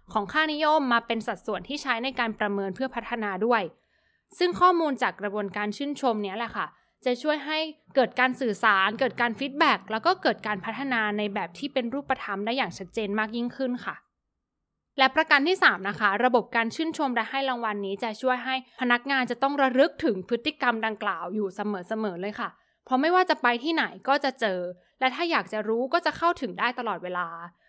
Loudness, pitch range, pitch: -26 LUFS, 210-275 Hz, 240 Hz